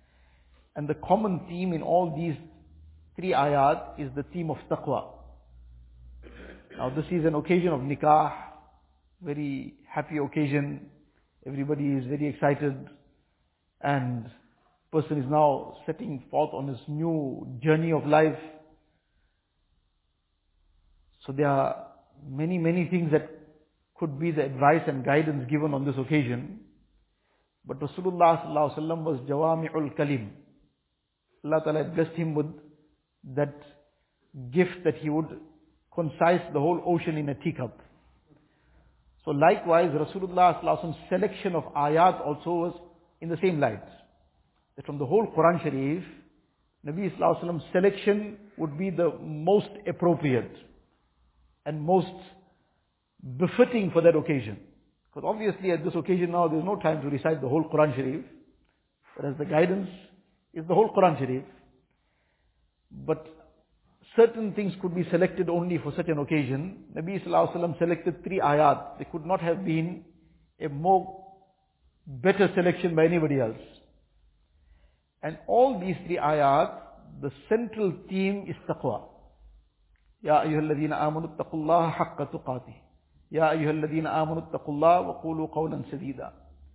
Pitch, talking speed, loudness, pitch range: 155 Hz, 135 wpm, -27 LUFS, 135-170 Hz